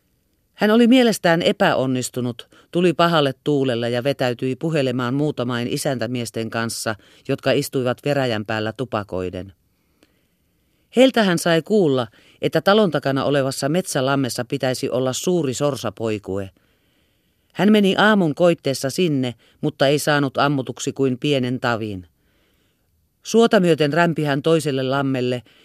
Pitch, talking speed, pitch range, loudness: 135 Hz, 115 wpm, 120-155 Hz, -20 LUFS